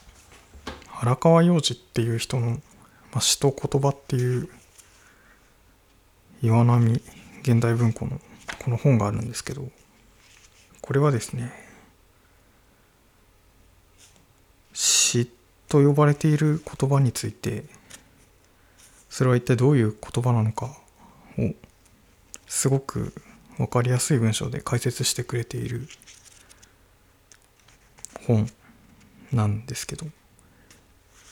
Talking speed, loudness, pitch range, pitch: 195 characters per minute, -23 LUFS, 100-130 Hz, 115 Hz